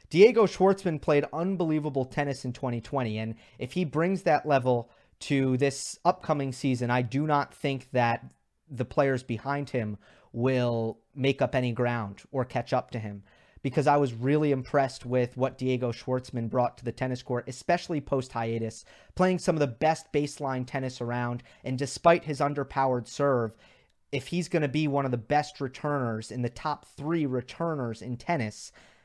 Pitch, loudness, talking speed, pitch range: 130 Hz, -28 LUFS, 170 wpm, 120-150 Hz